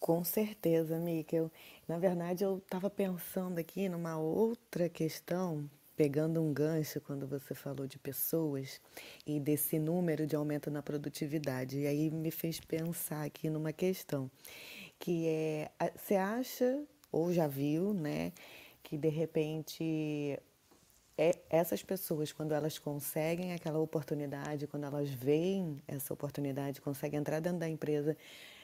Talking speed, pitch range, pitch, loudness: 130 wpm, 150-170 Hz, 155 Hz, -36 LUFS